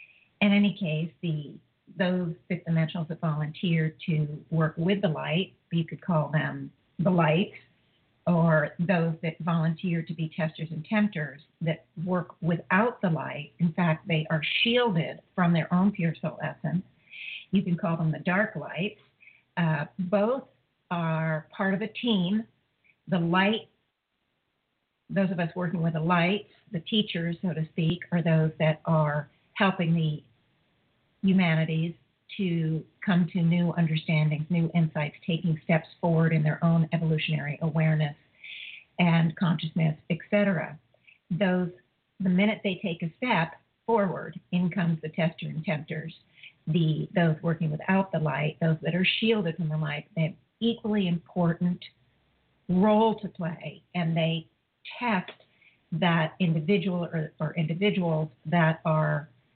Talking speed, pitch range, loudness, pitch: 145 wpm, 155-185 Hz, -27 LUFS, 165 Hz